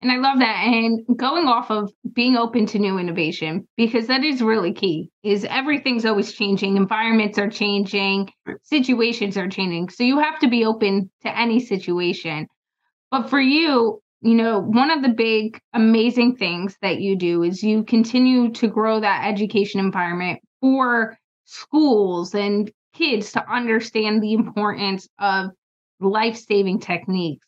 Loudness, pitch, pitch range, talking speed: -20 LUFS, 220 Hz, 195-235 Hz, 155 wpm